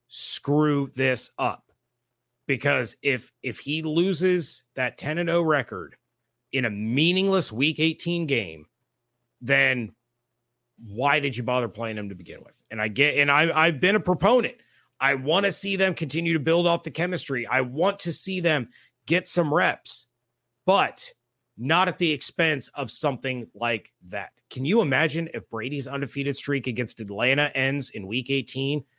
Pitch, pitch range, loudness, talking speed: 140 Hz, 120-165 Hz, -24 LUFS, 165 wpm